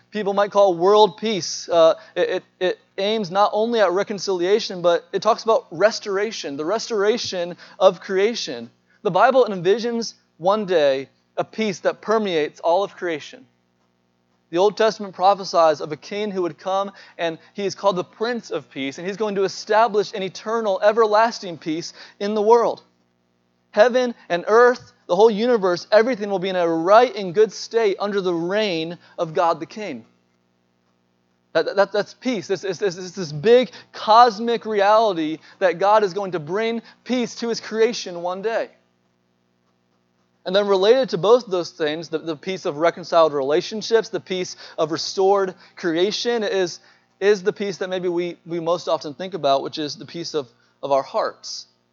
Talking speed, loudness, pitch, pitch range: 175 wpm, -20 LUFS, 190 Hz, 165-215 Hz